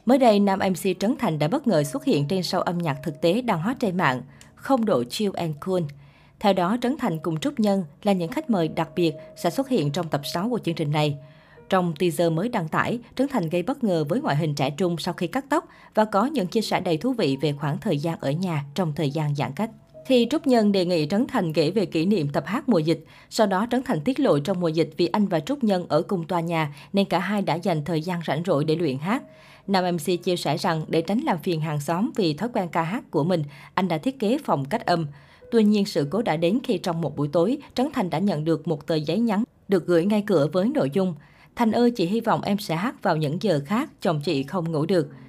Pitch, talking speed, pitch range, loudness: 180 Hz, 265 wpm, 160-220 Hz, -24 LUFS